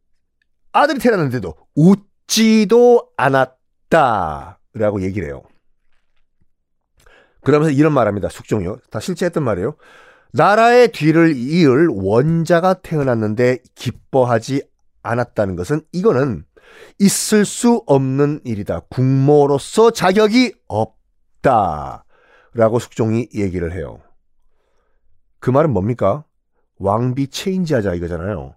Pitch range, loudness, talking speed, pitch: 105-165 Hz, -16 LUFS, 250 characters per minute, 130 Hz